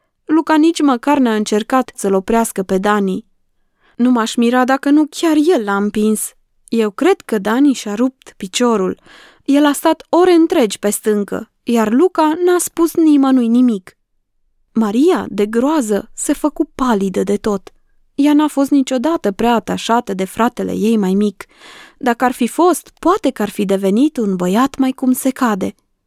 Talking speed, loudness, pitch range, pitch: 165 wpm, -15 LUFS, 210-295 Hz, 245 Hz